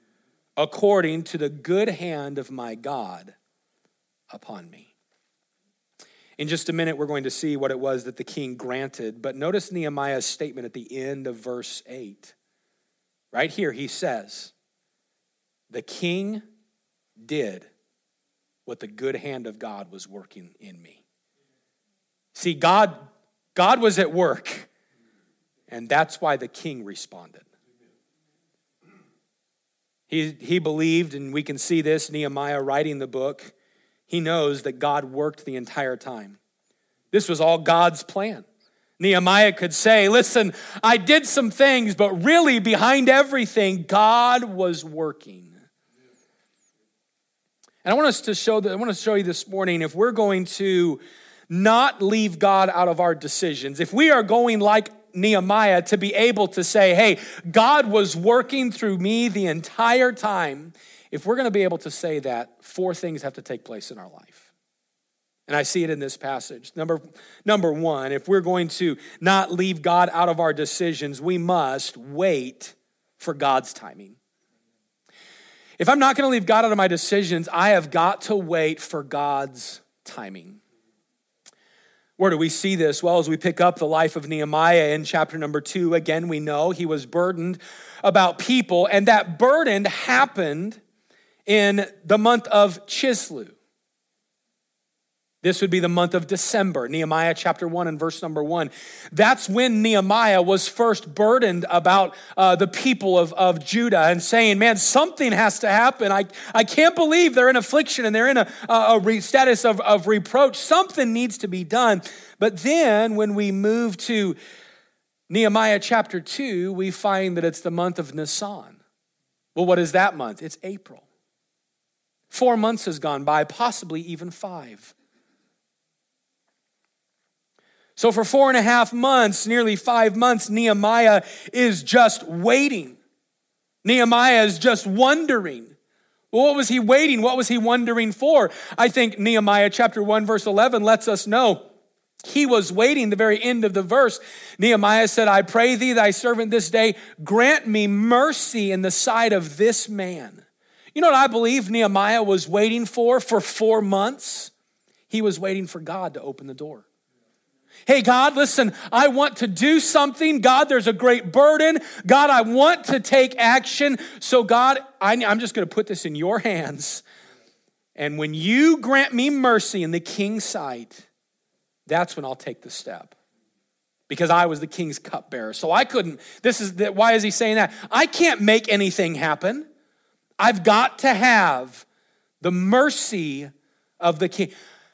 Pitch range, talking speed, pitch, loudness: 165-230 Hz, 160 wpm, 200 Hz, -19 LUFS